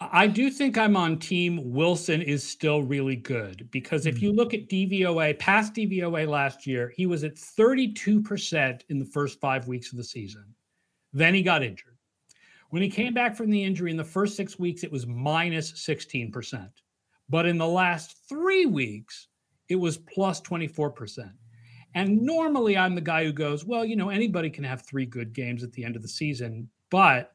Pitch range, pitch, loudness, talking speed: 130-190 Hz, 160 Hz, -26 LUFS, 190 wpm